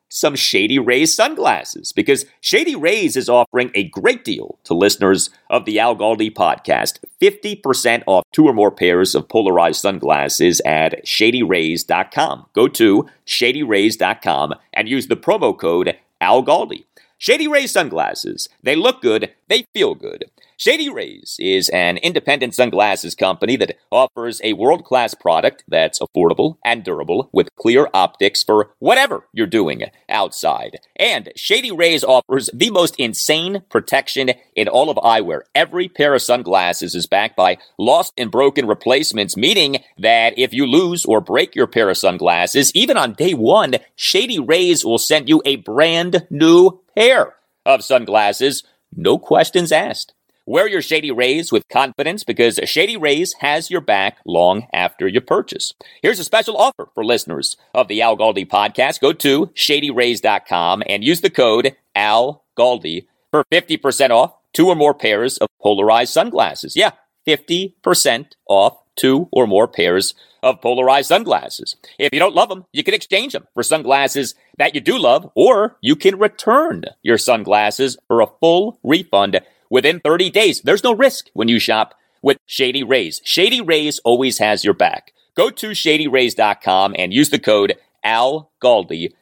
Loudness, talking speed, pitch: -15 LUFS, 155 wpm, 165 Hz